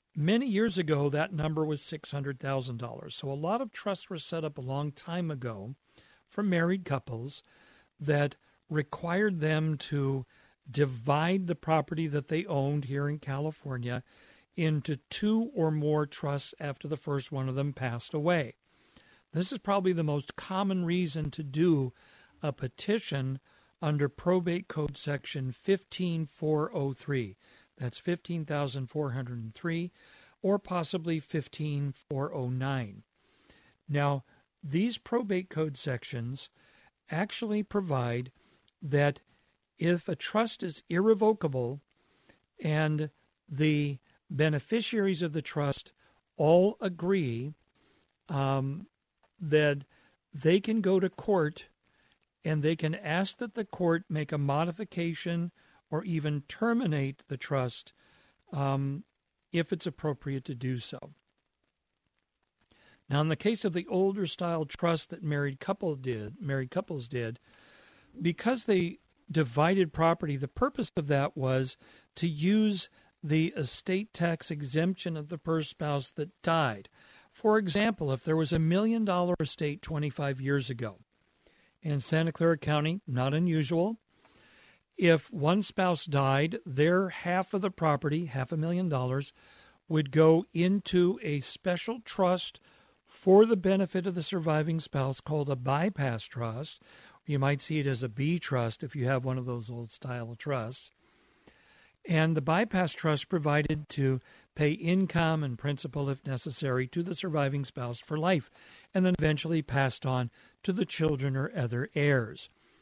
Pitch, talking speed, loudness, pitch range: 155 Hz, 135 wpm, -31 LUFS, 140-175 Hz